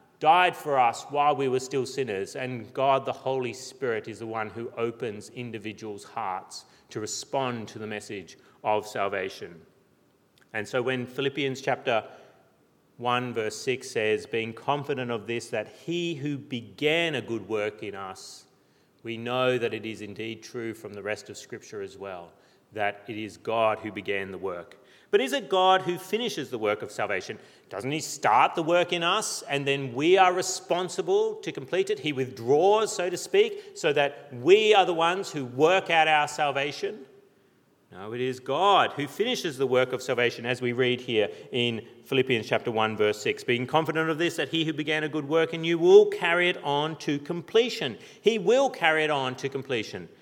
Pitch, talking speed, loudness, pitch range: 140 Hz, 190 wpm, -26 LUFS, 115-175 Hz